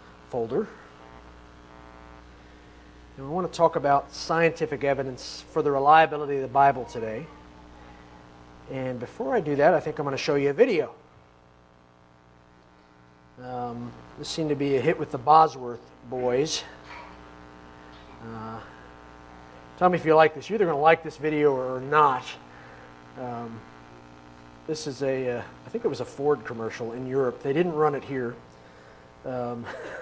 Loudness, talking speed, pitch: -25 LUFS, 155 wpm, 115 Hz